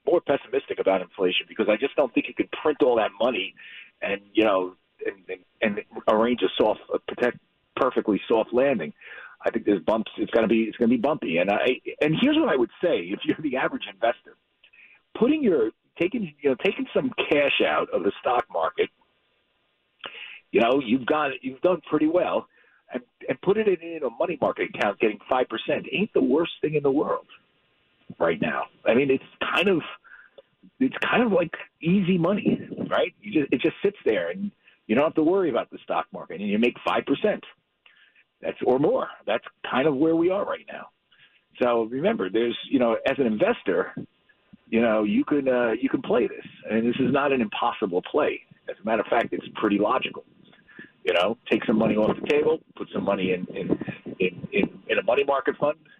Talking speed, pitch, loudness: 210 wpm, 175 Hz, -24 LUFS